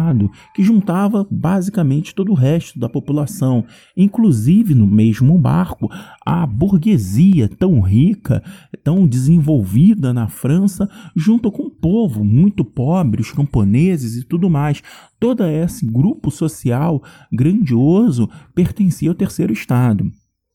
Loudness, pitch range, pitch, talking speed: -15 LUFS, 130-190 Hz, 165 Hz, 115 wpm